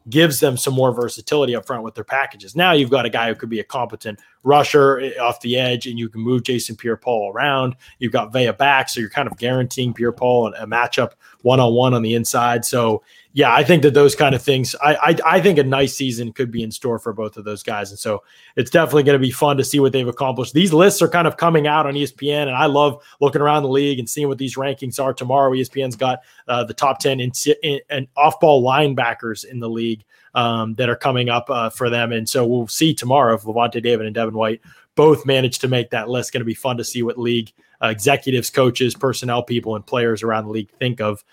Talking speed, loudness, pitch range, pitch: 255 wpm, -18 LUFS, 120-140 Hz, 125 Hz